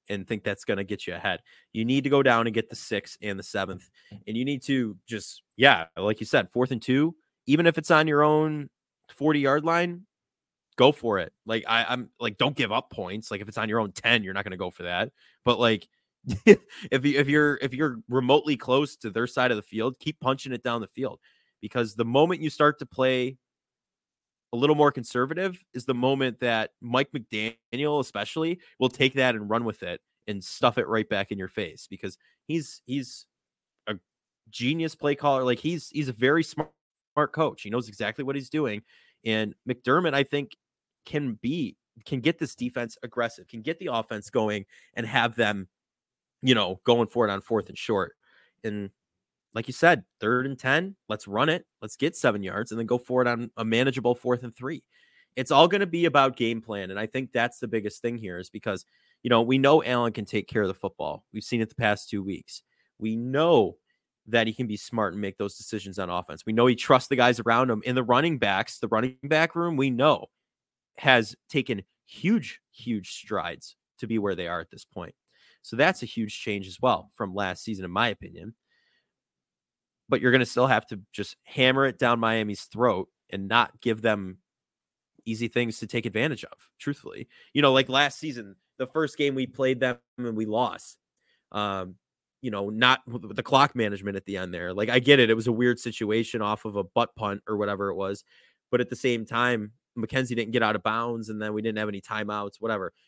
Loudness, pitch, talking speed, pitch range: -26 LUFS, 120 Hz, 215 wpm, 110-135 Hz